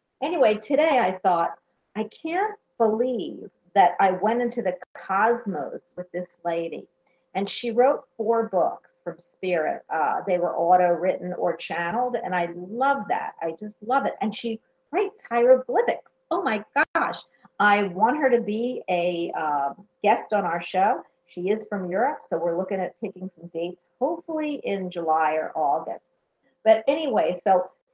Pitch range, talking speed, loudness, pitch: 180-245 Hz, 160 wpm, -24 LUFS, 205 Hz